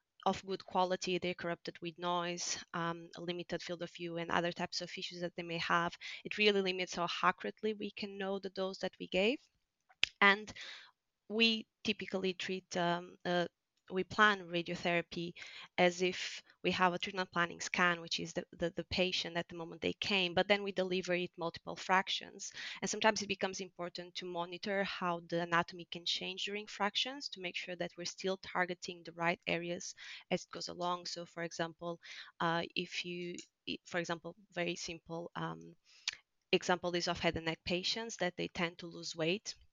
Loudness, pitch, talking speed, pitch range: -37 LUFS, 175 Hz, 185 wpm, 170-190 Hz